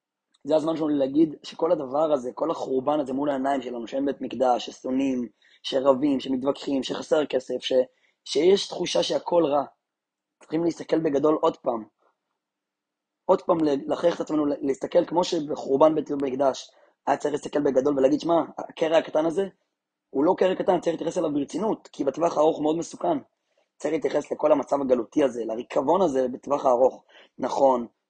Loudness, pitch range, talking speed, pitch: -25 LUFS, 135-165 Hz, 160 wpm, 145 Hz